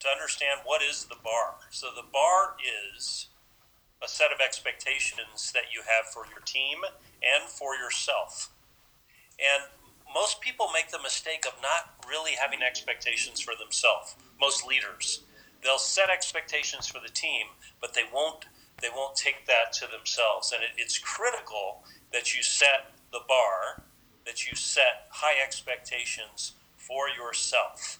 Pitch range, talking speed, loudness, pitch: 125-150 Hz, 150 wpm, -28 LUFS, 135 Hz